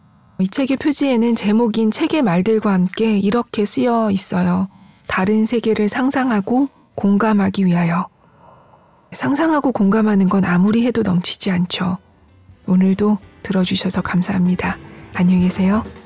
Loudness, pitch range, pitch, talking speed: -17 LUFS, 185-230 Hz, 205 Hz, 295 characters per minute